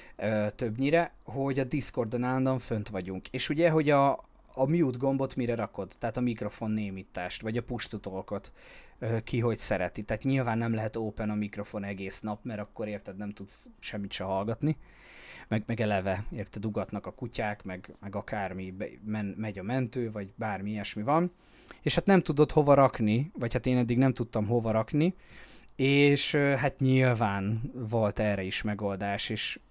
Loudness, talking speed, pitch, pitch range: -30 LUFS, 175 wpm, 110 Hz, 105-130 Hz